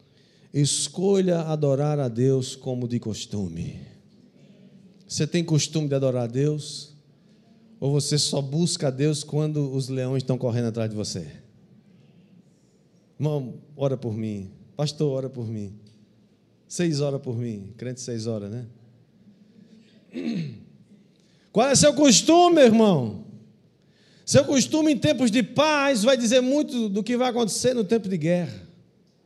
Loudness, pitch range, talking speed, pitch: -23 LUFS, 130-205 Hz, 135 wpm, 150 Hz